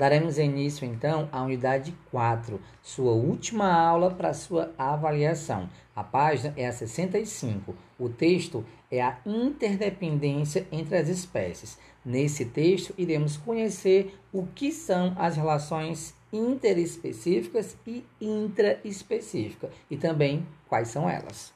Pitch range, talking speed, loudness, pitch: 135-185 Hz, 115 wpm, -28 LUFS, 160 Hz